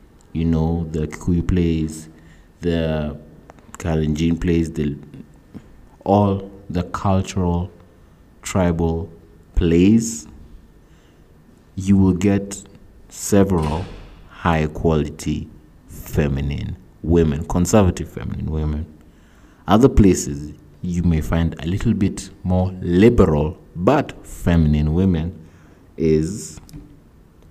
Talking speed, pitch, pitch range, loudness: 85 wpm, 85 Hz, 80-90 Hz, -20 LUFS